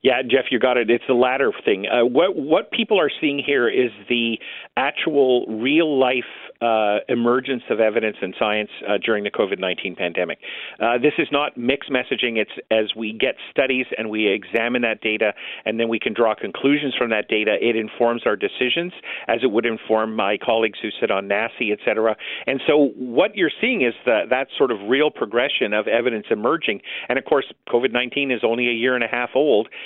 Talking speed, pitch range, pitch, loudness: 205 wpm, 110-130 Hz, 120 Hz, -20 LUFS